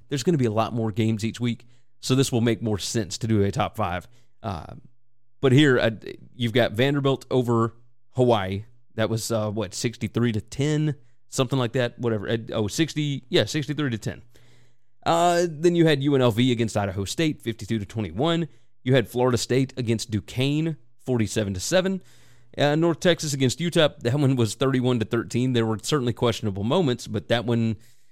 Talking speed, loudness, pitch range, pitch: 185 wpm, -24 LUFS, 115-135 Hz, 120 Hz